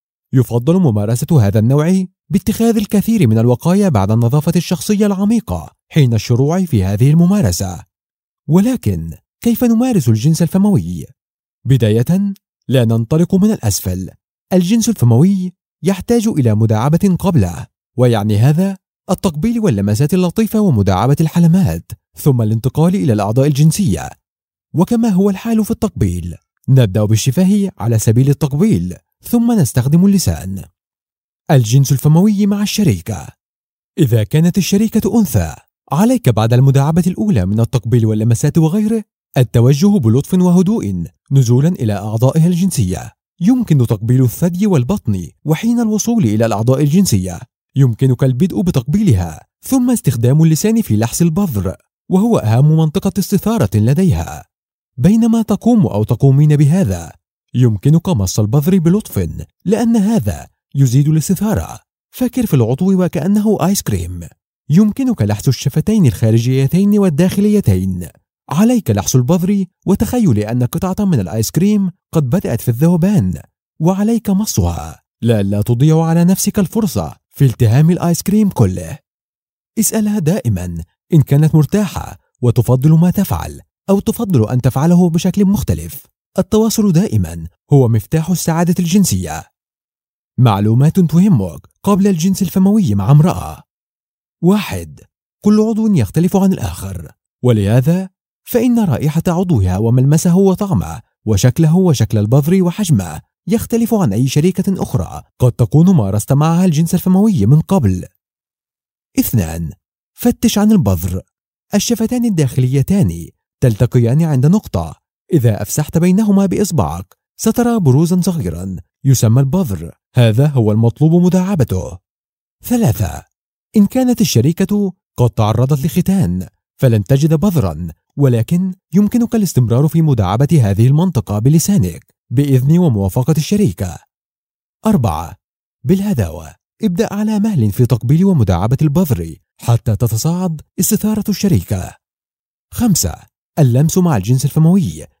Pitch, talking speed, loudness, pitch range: 155 Hz, 110 wpm, -14 LUFS, 115-195 Hz